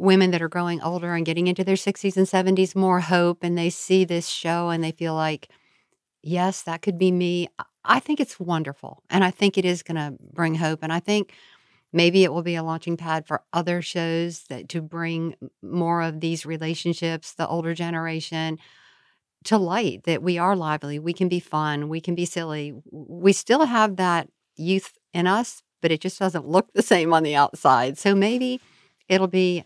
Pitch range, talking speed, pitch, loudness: 165-185 Hz, 200 wpm, 170 Hz, -23 LUFS